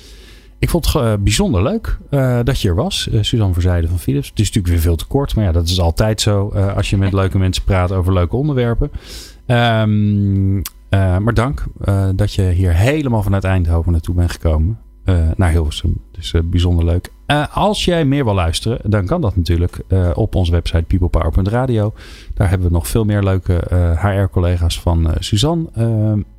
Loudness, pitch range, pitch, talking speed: -16 LUFS, 85-110 Hz, 95 Hz, 200 wpm